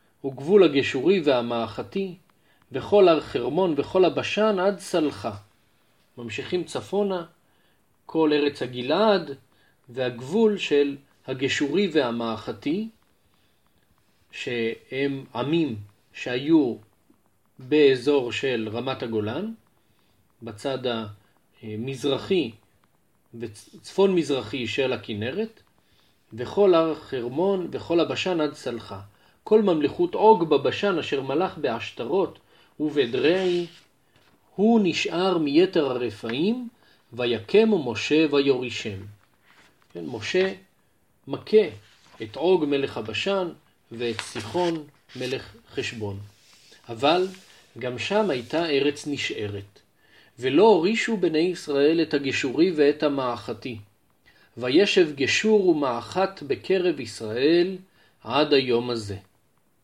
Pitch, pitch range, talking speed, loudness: 145 Hz, 120-185 Hz, 85 wpm, -24 LUFS